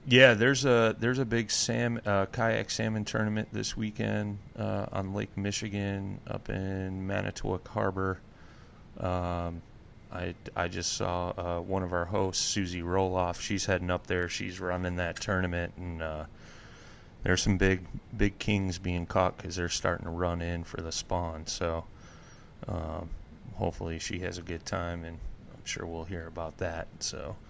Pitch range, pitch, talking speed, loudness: 85-105 Hz, 95 Hz, 165 wpm, -31 LUFS